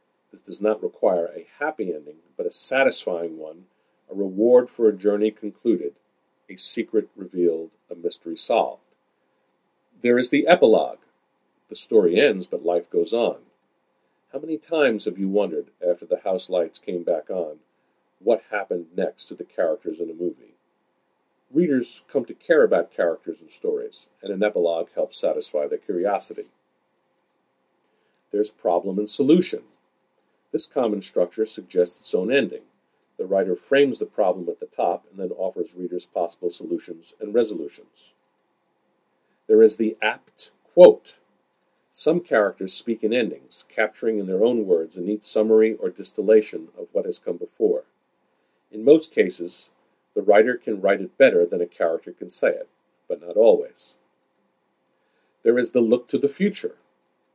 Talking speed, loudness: 155 wpm, -22 LUFS